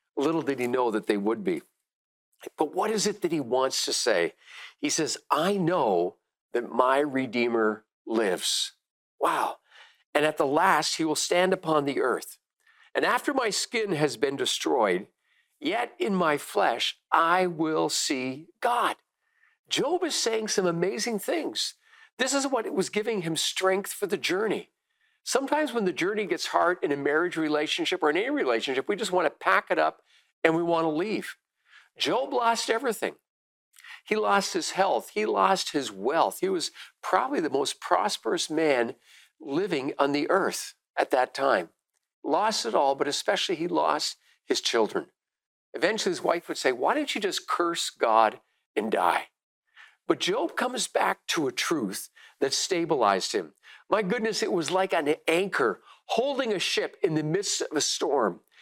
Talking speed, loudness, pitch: 170 wpm, -26 LUFS, 225 Hz